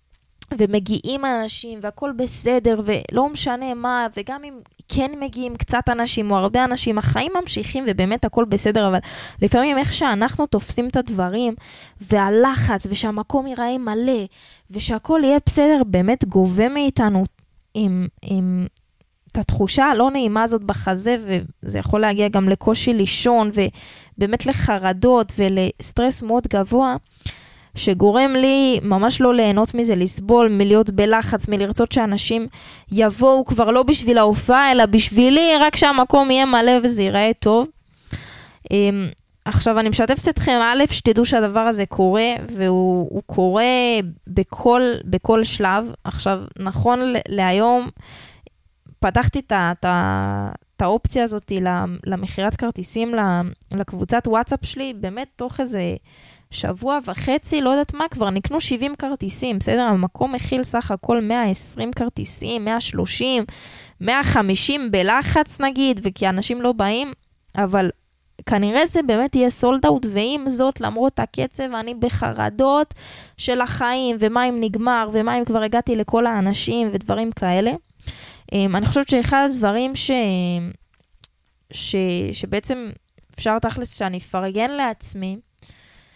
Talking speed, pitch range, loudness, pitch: 120 wpm, 200-250 Hz, -19 LUFS, 225 Hz